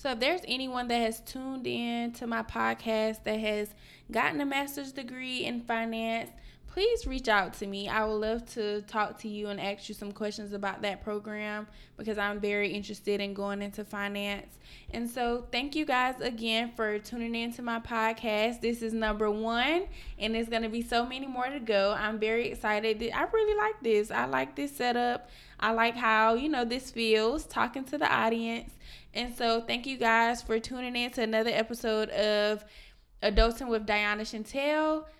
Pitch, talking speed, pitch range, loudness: 225 Hz, 190 wpm, 210-245 Hz, -30 LUFS